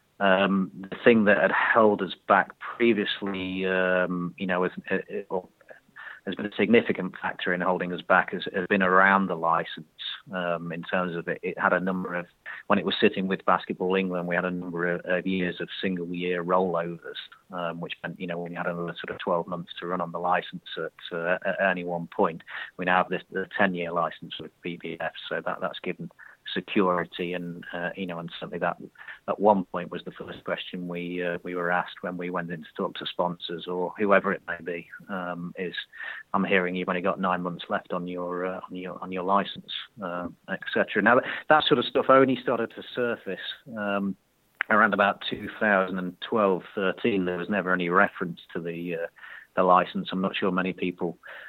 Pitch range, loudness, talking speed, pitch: 90-95 Hz, -27 LUFS, 210 wpm, 90 Hz